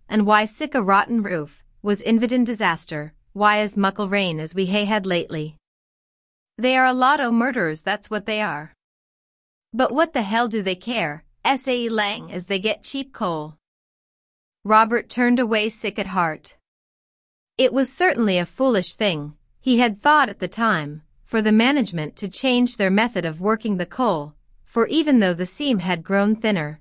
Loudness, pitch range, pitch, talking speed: -21 LUFS, 180-240 Hz, 210 Hz, 175 wpm